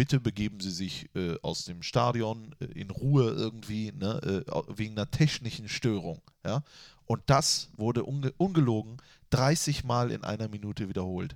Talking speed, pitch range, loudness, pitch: 160 wpm, 105-135 Hz, -30 LUFS, 115 Hz